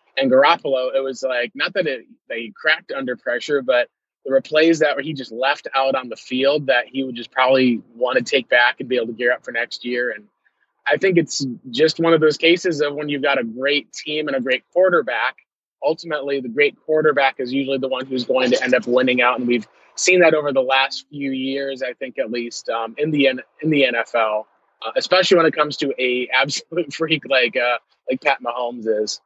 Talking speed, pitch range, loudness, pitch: 230 wpm, 125-150 Hz, -19 LUFS, 135 Hz